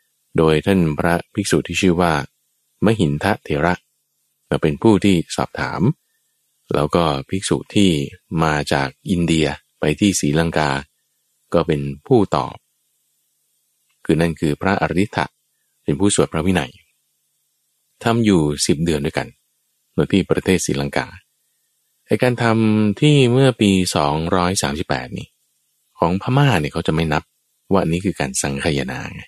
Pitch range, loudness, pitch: 75-95 Hz, -18 LUFS, 80 Hz